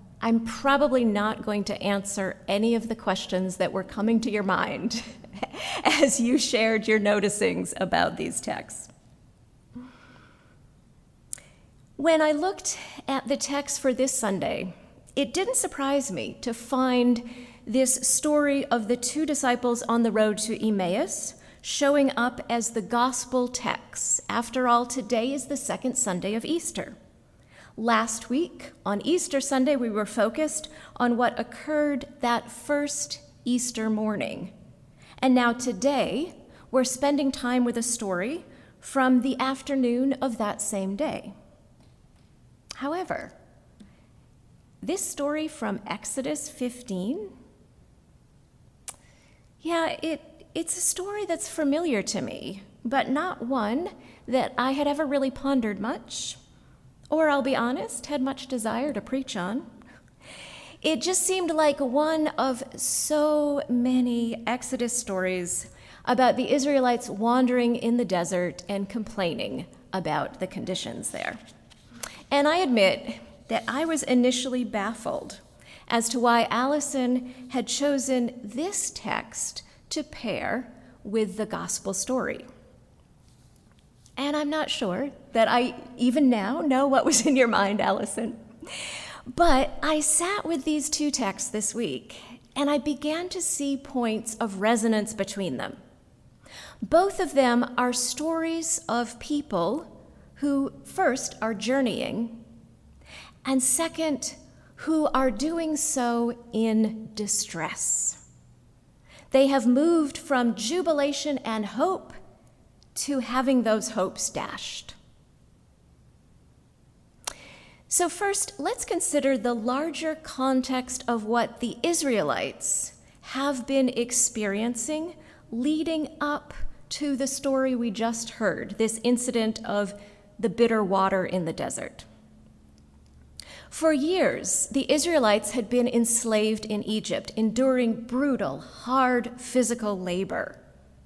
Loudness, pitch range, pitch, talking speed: -26 LUFS, 225-285 Hz, 250 Hz, 120 wpm